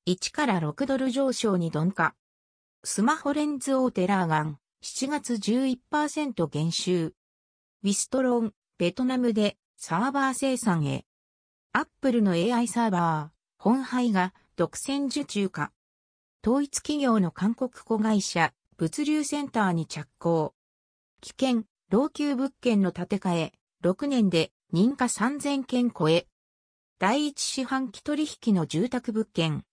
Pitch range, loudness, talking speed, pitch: 165-260 Hz, -27 LUFS, 225 characters per minute, 205 Hz